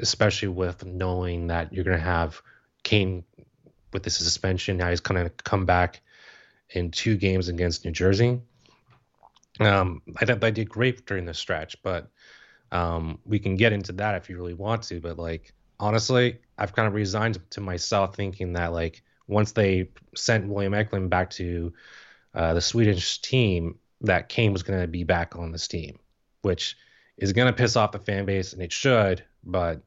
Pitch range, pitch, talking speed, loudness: 90-105 Hz, 95 Hz, 185 wpm, -25 LUFS